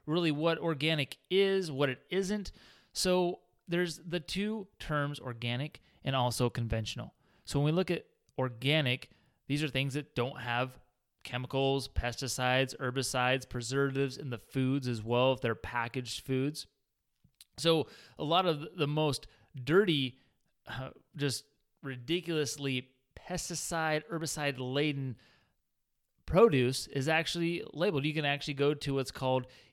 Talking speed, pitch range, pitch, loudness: 130 wpm, 125-155 Hz, 140 Hz, -32 LUFS